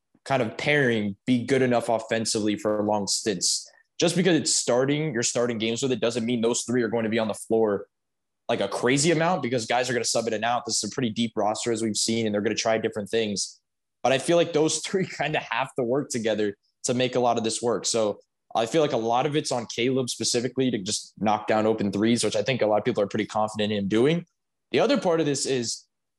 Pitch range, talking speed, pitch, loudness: 110-130 Hz, 260 wpm, 120 Hz, -25 LUFS